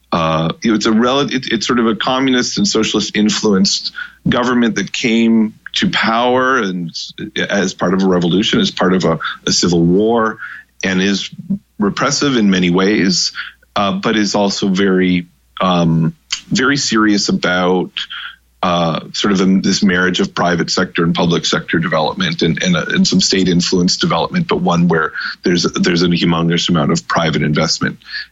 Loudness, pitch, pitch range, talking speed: -14 LUFS, 105 Hz, 90-130 Hz, 165 wpm